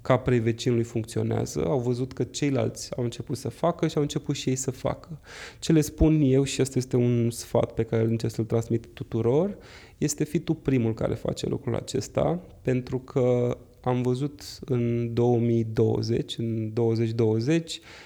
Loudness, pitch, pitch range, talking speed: -26 LUFS, 125 Hz, 115-135 Hz, 165 wpm